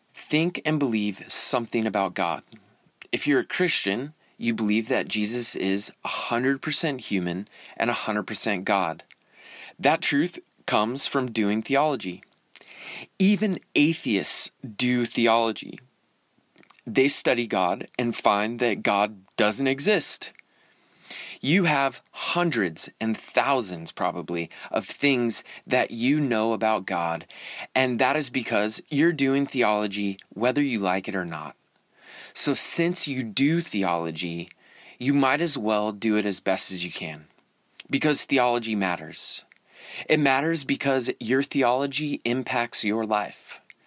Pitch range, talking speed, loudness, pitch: 100-140 Hz, 125 wpm, -24 LUFS, 120 Hz